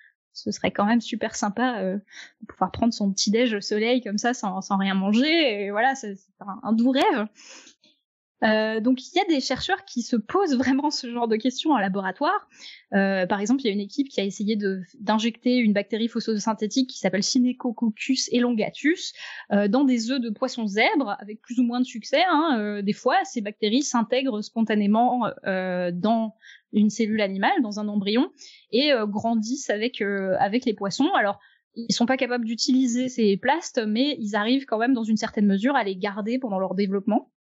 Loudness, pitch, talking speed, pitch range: -24 LUFS, 230 Hz, 205 wpm, 205-255 Hz